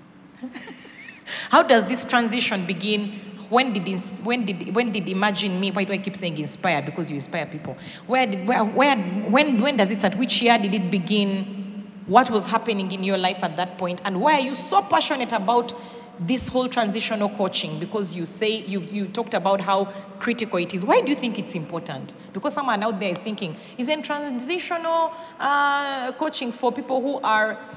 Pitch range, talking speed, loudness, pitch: 195-250 Hz, 190 wpm, -22 LUFS, 215 Hz